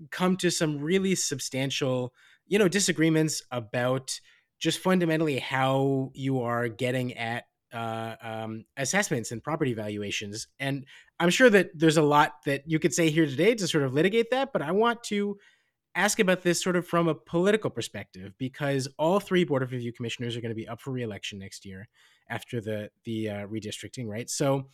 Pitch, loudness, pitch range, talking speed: 135 Hz, -27 LUFS, 120-170 Hz, 185 wpm